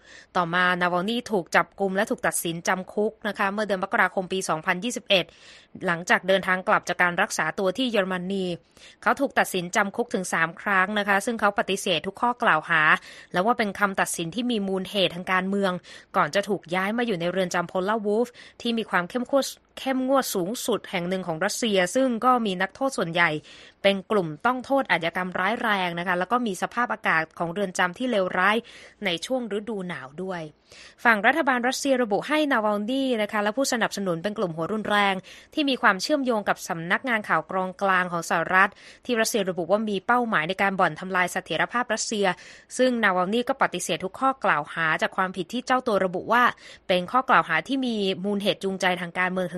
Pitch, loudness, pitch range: 195 Hz, -24 LUFS, 180-230 Hz